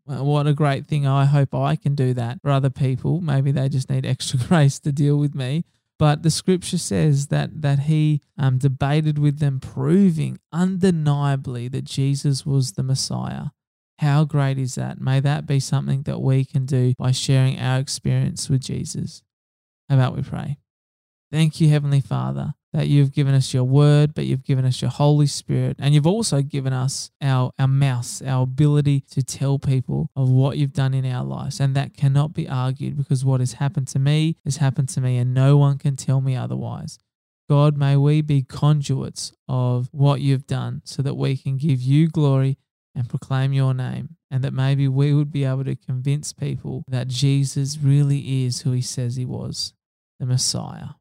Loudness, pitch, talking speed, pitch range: -21 LUFS, 140 Hz, 190 wpm, 130-145 Hz